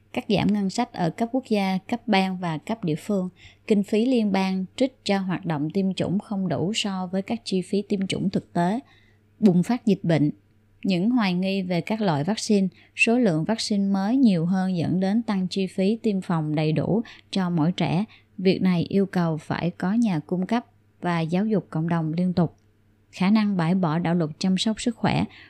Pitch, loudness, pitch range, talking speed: 190 Hz, -24 LUFS, 170-205 Hz, 210 wpm